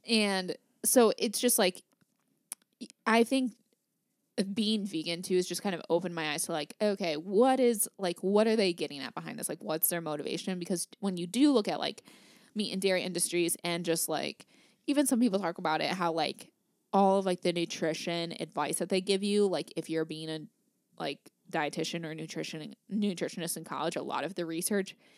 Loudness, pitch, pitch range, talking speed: -31 LUFS, 185 Hz, 165-220 Hz, 200 wpm